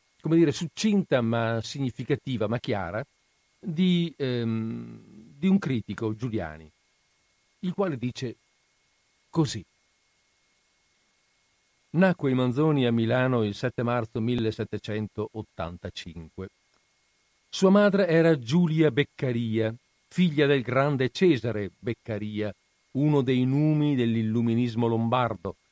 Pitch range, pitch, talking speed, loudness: 110-150 Hz, 125 Hz, 95 wpm, -26 LUFS